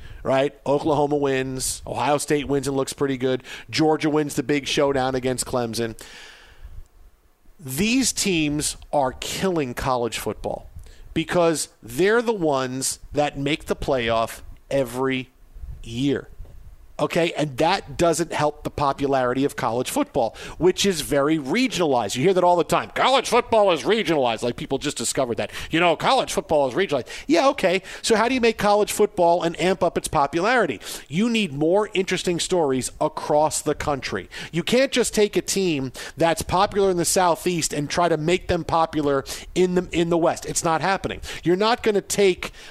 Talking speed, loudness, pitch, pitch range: 170 wpm, -22 LUFS, 155 Hz, 135-185 Hz